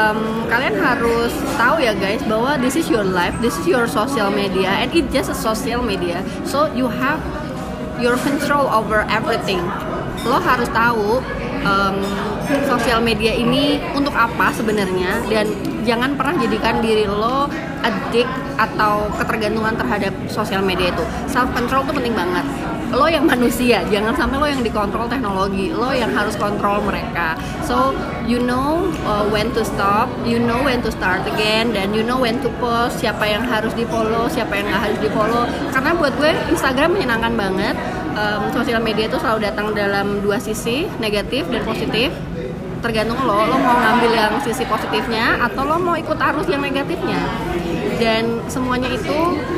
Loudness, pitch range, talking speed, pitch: -18 LUFS, 215-255 Hz, 165 wpm, 230 Hz